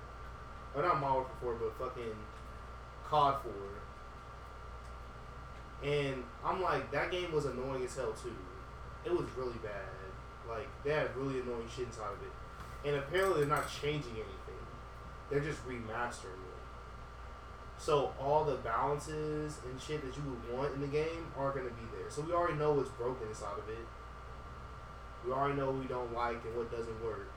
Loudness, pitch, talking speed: -37 LUFS, 120 Hz, 175 wpm